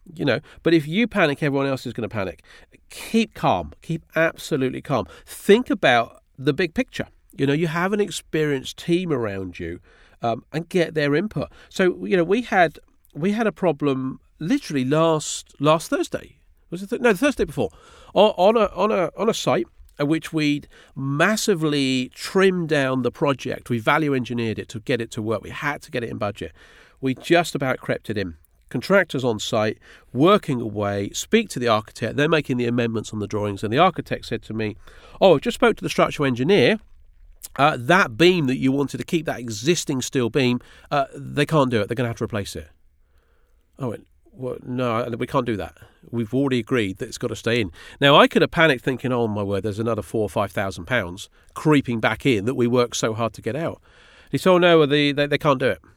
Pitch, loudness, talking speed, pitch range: 135 Hz, -22 LUFS, 215 wpm, 115-160 Hz